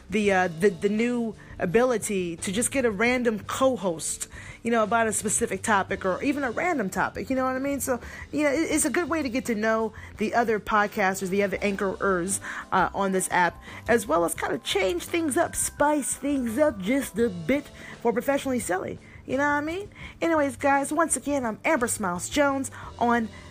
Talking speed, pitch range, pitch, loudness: 210 wpm, 200-275 Hz, 235 Hz, -25 LUFS